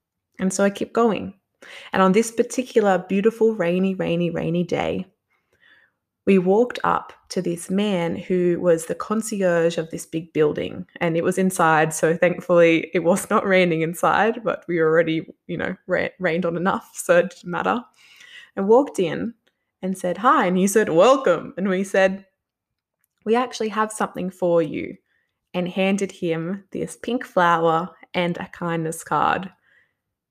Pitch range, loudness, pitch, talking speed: 170-215 Hz, -21 LUFS, 185 Hz, 160 wpm